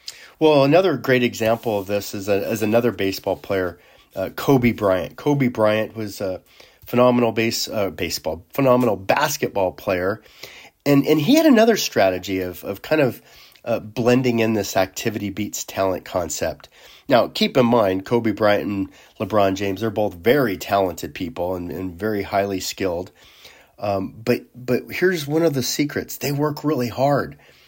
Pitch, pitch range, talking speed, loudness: 115 Hz, 100-130 Hz, 160 wpm, -20 LUFS